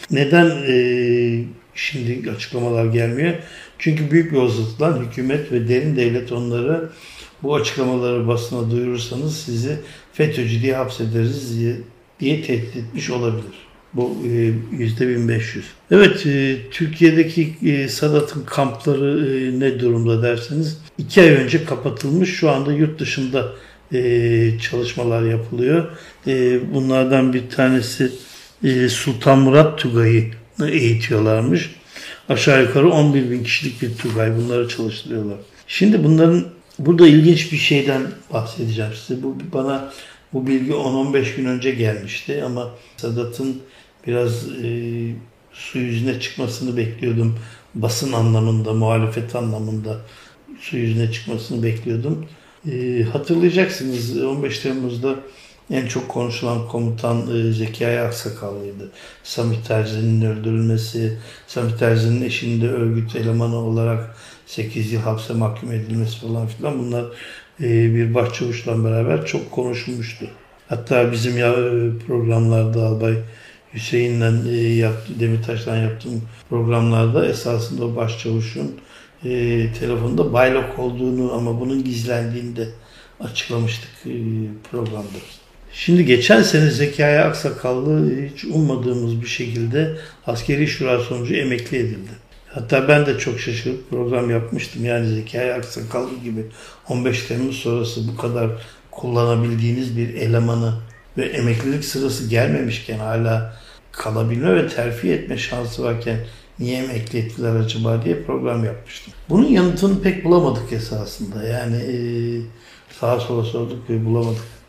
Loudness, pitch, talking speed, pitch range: -19 LUFS, 120 Hz, 110 wpm, 115-135 Hz